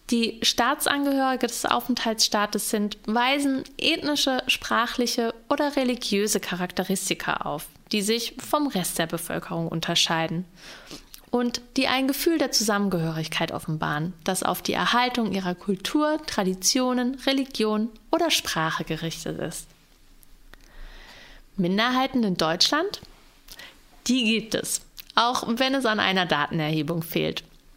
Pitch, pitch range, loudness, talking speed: 225 Hz, 180-260 Hz, -24 LUFS, 110 wpm